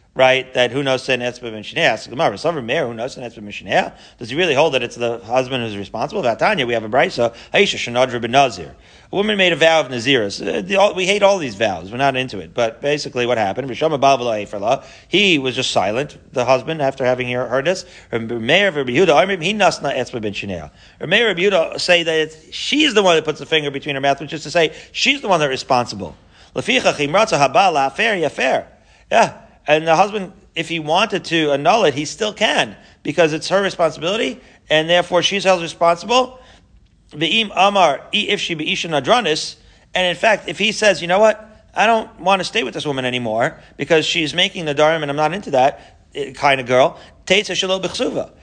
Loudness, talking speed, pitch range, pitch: -17 LUFS, 175 wpm, 125-185 Hz, 155 Hz